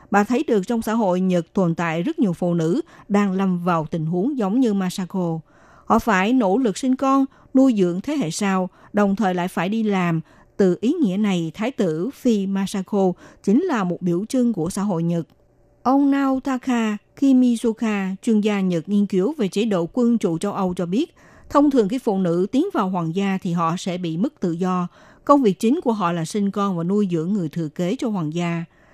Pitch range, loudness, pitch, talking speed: 180-235 Hz, -21 LUFS, 200 Hz, 220 wpm